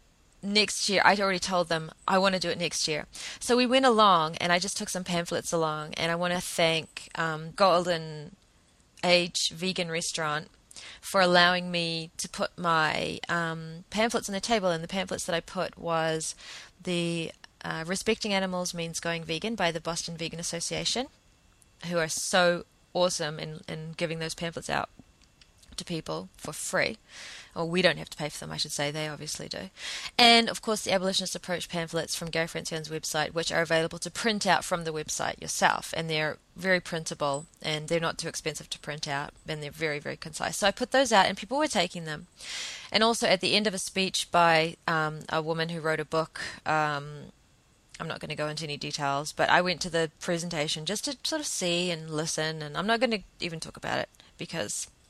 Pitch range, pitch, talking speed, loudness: 160-185 Hz, 170 Hz, 205 wpm, -28 LUFS